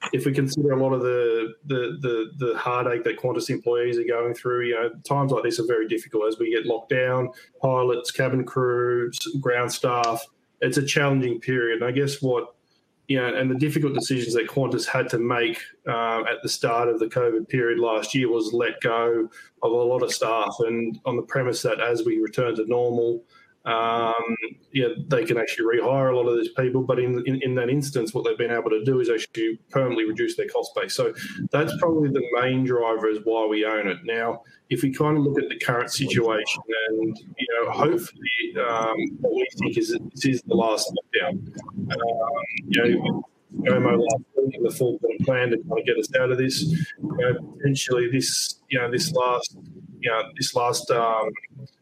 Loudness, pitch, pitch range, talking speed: -24 LUFS, 130 Hz, 120-155 Hz, 205 wpm